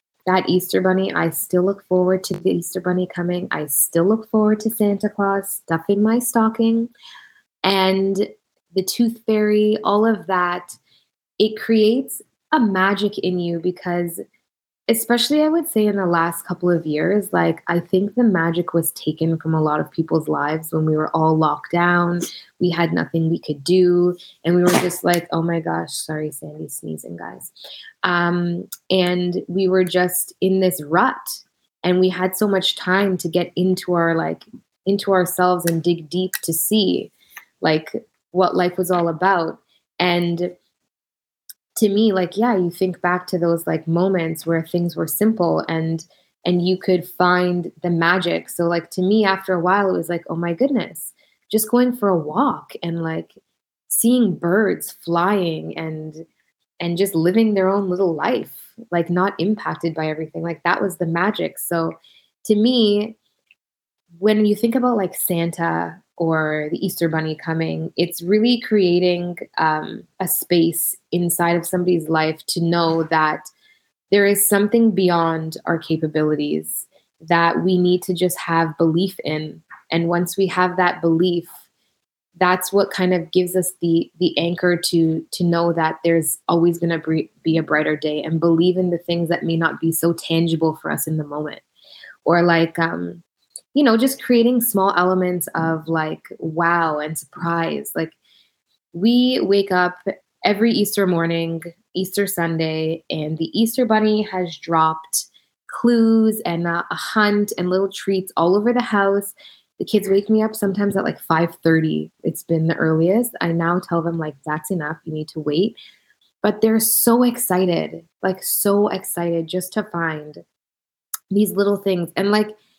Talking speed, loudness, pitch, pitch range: 170 wpm, -19 LUFS, 180 Hz, 165-200 Hz